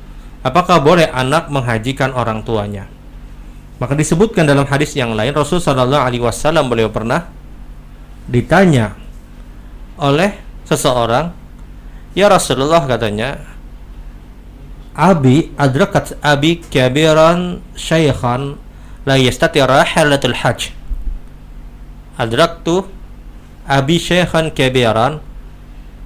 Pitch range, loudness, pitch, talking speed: 115-160 Hz, -14 LUFS, 140 Hz, 80 wpm